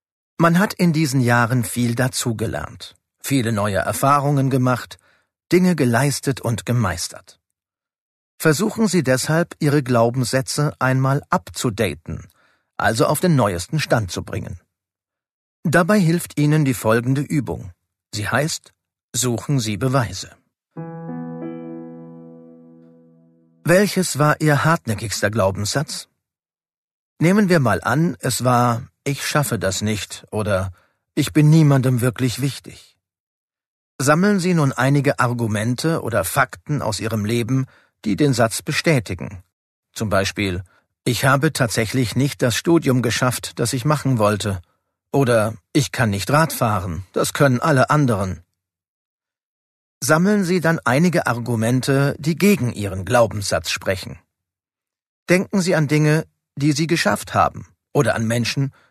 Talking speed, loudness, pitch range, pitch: 120 wpm, -19 LUFS, 105-150 Hz, 125 Hz